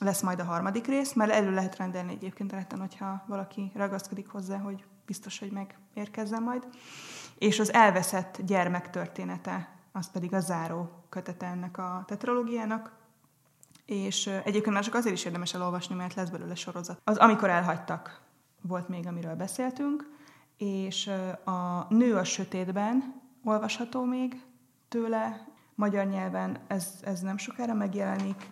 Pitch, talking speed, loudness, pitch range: 195 Hz, 140 wpm, -31 LUFS, 180-215 Hz